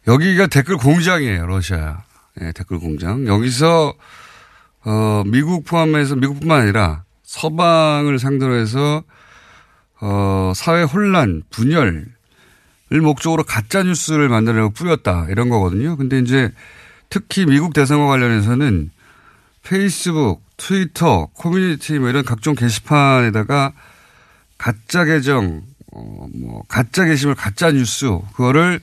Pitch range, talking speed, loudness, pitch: 105-160 Hz, 270 characters per minute, -16 LUFS, 135 Hz